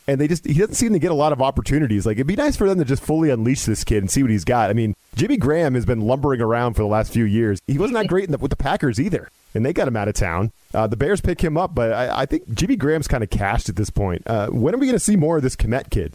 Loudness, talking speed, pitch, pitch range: -20 LUFS, 330 wpm, 130 Hz, 110-155 Hz